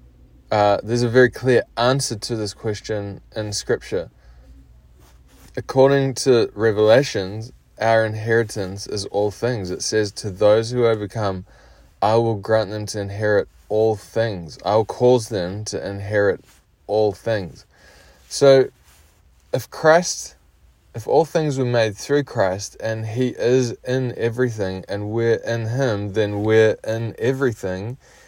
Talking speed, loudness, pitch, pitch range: 135 wpm, -20 LUFS, 110 Hz, 95-115 Hz